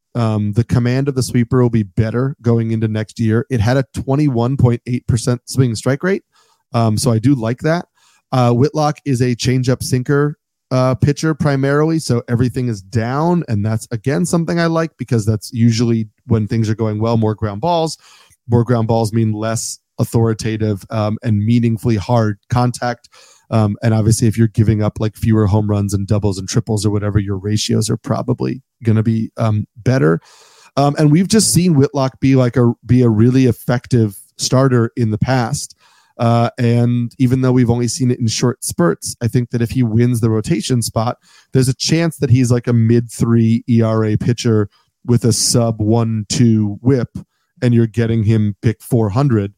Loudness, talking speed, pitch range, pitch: -16 LUFS, 185 wpm, 110-130 Hz, 120 Hz